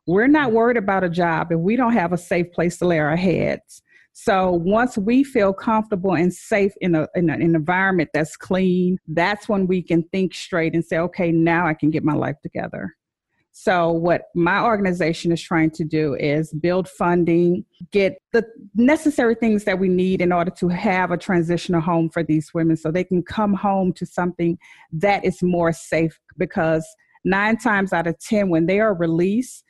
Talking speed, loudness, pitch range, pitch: 200 wpm, -20 LUFS, 165-200 Hz, 180 Hz